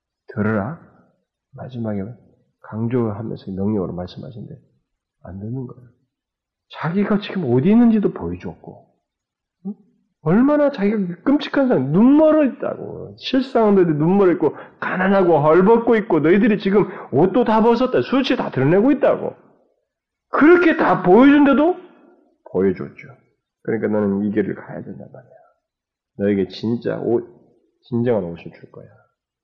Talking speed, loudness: 285 characters per minute, -17 LUFS